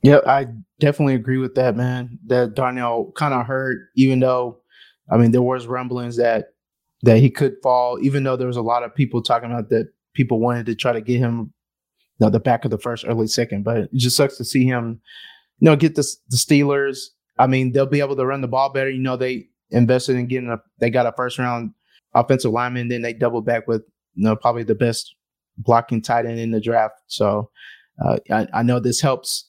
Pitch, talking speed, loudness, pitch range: 125 Hz, 230 wpm, -19 LUFS, 115-130 Hz